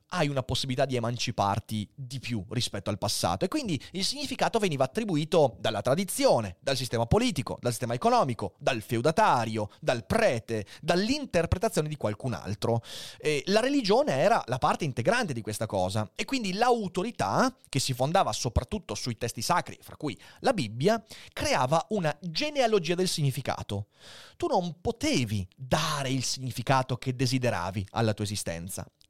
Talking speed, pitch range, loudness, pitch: 150 wpm, 110-185 Hz, -28 LUFS, 130 Hz